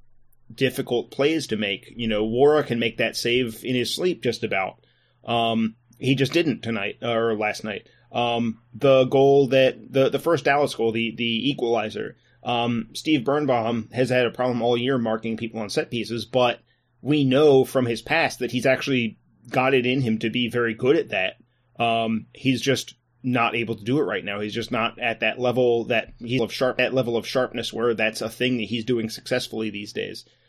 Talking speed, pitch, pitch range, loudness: 205 wpm, 120 Hz, 115-130 Hz, -23 LUFS